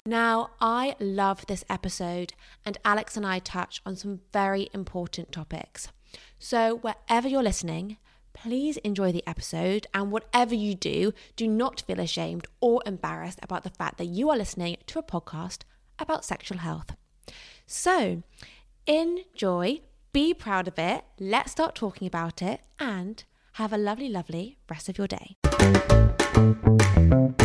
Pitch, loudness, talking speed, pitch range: 195 Hz, -27 LUFS, 145 wpm, 170-225 Hz